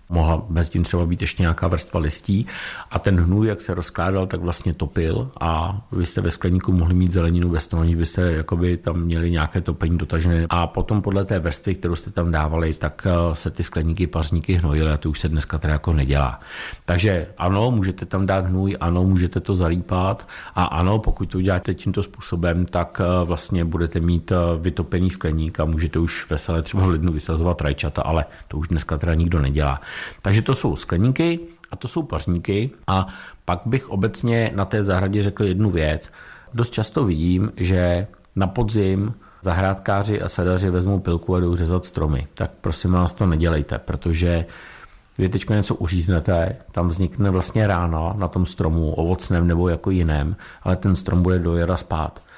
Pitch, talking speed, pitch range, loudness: 90 Hz, 180 wpm, 85-95 Hz, -21 LUFS